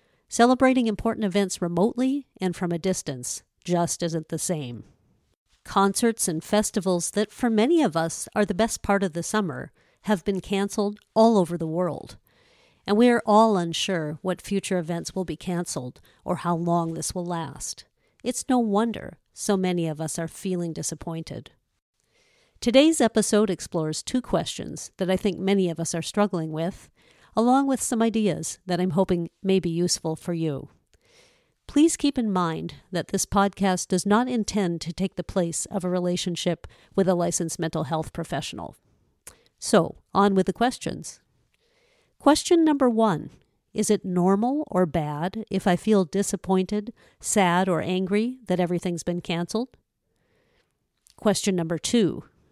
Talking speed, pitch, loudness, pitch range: 155 wpm, 190 Hz, -25 LUFS, 170-215 Hz